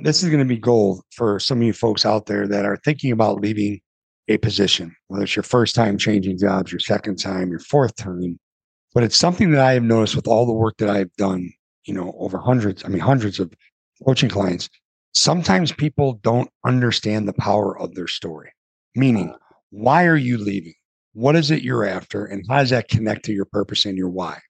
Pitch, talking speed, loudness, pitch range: 105 Hz, 215 wpm, -19 LUFS, 100-125 Hz